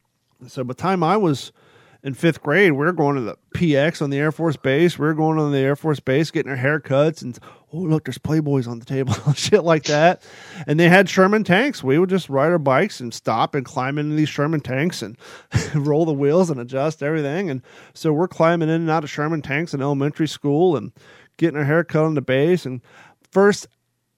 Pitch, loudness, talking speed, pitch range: 150 Hz, -19 LUFS, 230 wpm, 135-165 Hz